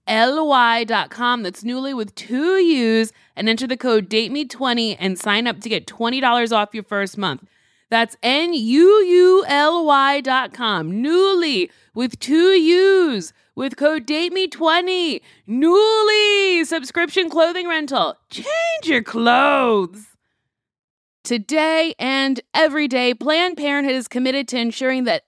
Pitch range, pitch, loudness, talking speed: 230-325 Hz, 265 Hz, -17 LUFS, 125 wpm